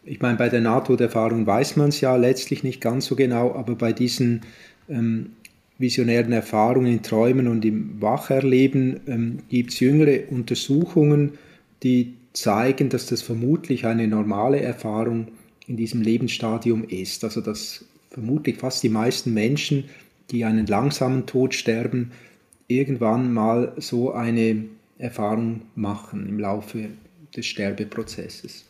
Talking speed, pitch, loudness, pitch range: 135 wpm, 120 Hz, -22 LUFS, 110-130 Hz